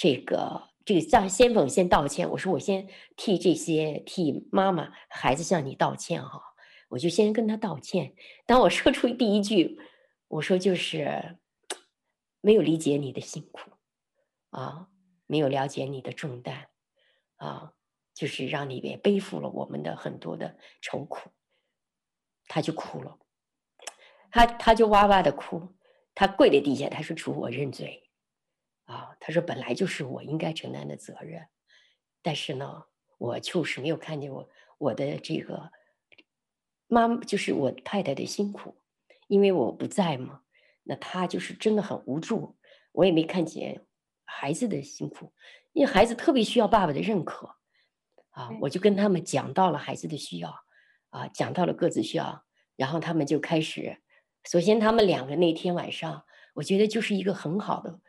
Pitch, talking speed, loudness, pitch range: 180 Hz, 235 characters per minute, -27 LUFS, 155-210 Hz